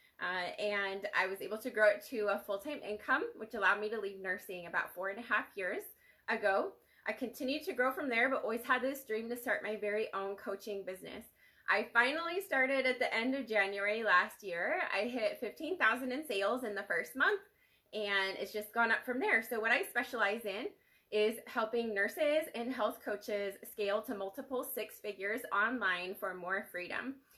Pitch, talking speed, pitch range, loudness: 220 Hz, 195 wpm, 200-260 Hz, -35 LUFS